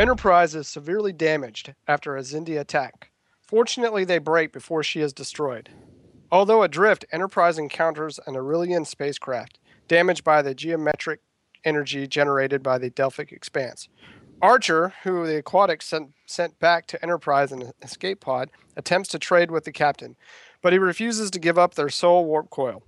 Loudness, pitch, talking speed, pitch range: -22 LUFS, 160 Hz, 160 wpm, 145-175 Hz